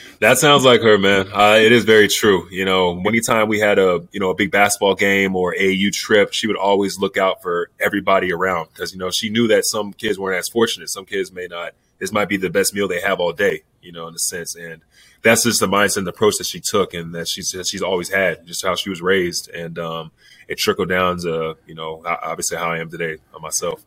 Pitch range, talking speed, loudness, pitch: 85-110 Hz, 255 wpm, -17 LUFS, 100 Hz